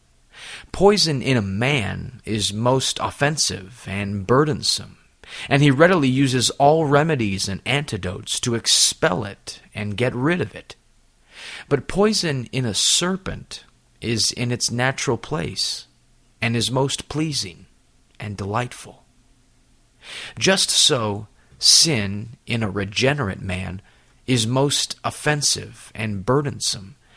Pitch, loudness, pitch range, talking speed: 120 Hz, -20 LUFS, 100-145 Hz, 115 wpm